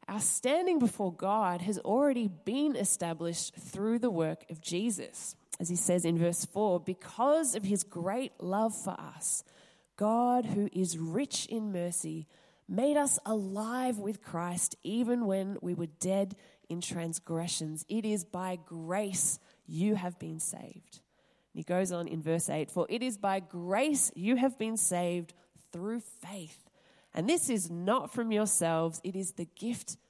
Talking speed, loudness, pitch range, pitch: 160 wpm, -32 LUFS, 175-220 Hz, 190 Hz